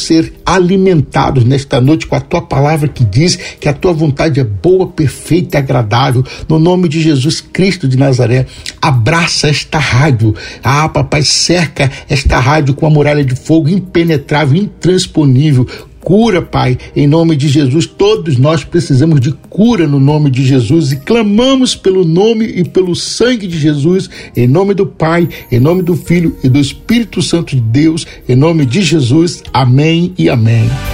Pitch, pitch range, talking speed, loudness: 155 Hz, 135-170 Hz, 170 wpm, -10 LUFS